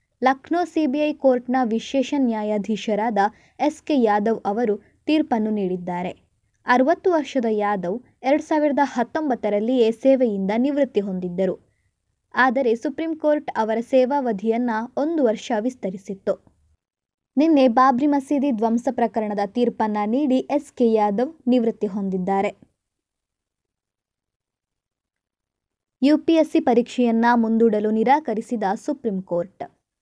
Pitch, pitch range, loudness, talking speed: 235 Hz, 210-275 Hz, -21 LUFS, 90 wpm